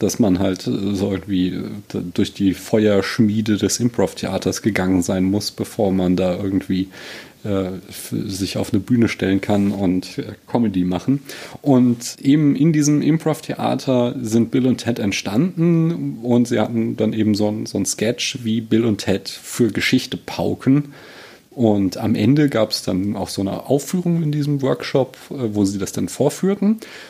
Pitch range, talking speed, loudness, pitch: 95-130 Hz, 155 wpm, -19 LUFS, 110 Hz